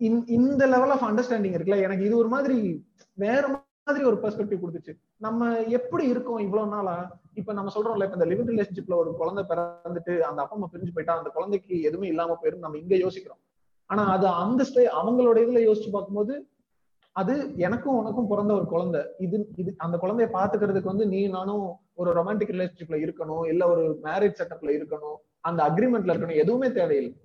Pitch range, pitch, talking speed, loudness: 170-230 Hz, 200 Hz, 165 wpm, -26 LUFS